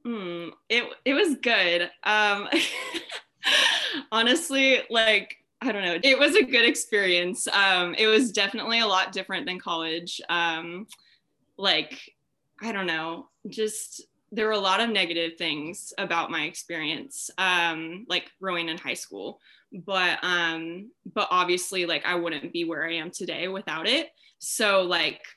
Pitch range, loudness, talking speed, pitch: 170-225 Hz, -24 LUFS, 150 wpm, 190 Hz